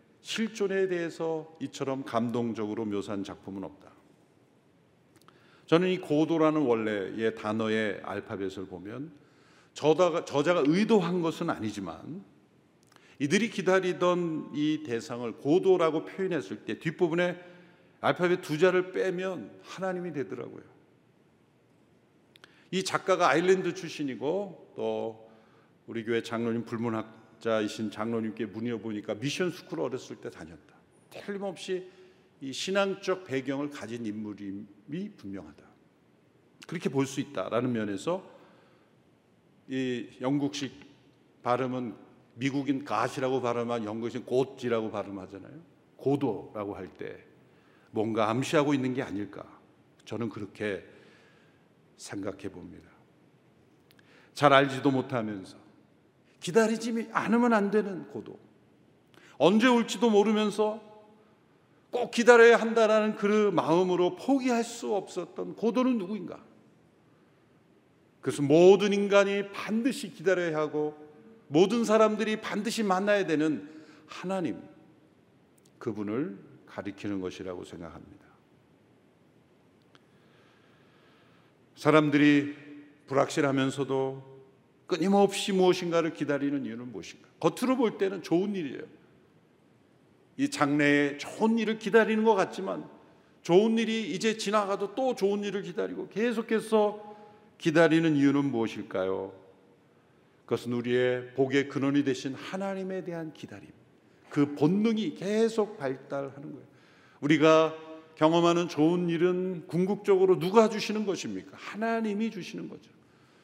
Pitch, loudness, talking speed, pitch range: 155 Hz, -28 LUFS, 265 characters per minute, 125-195 Hz